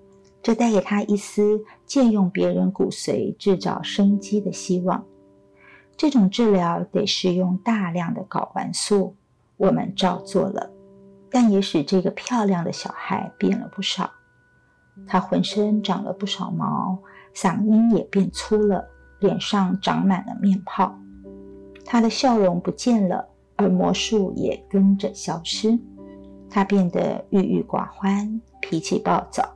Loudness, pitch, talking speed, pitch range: -22 LUFS, 195 Hz, 200 characters per minute, 185-210 Hz